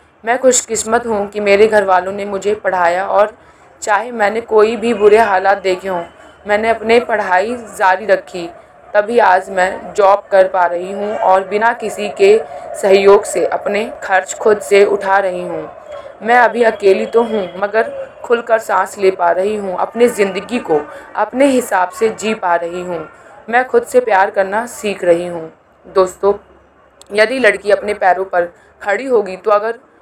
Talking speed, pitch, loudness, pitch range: 170 wpm, 205 Hz, -14 LUFS, 190-225 Hz